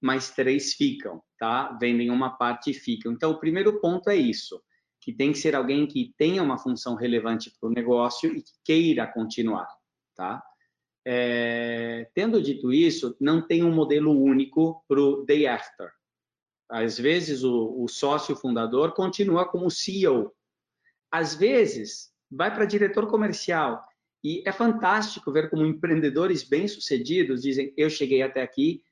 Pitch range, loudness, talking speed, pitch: 125-190 Hz, -25 LUFS, 155 wpm, 145 Hz